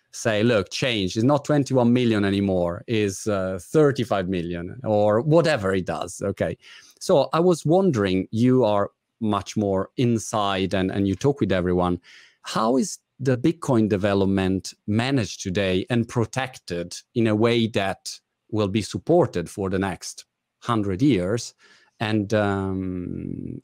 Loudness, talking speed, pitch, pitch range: -23 LUFS, 140 wpm, 105 Hz, 95-125 Hz